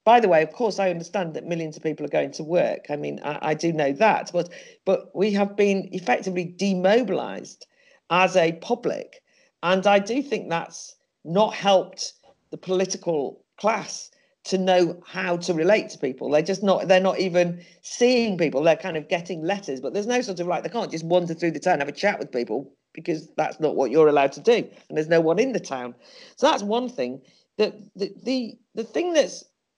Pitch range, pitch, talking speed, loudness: 165-210 Hz, 185 Hz, 215 wpm, -23 LUFS